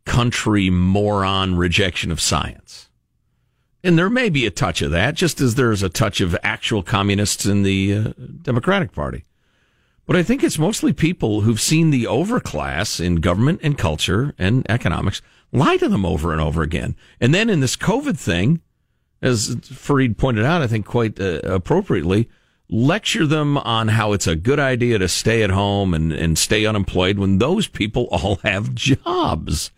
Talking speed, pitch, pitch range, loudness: 175 wpm, 105 Hz, 95-130 Hz, -19 LUFS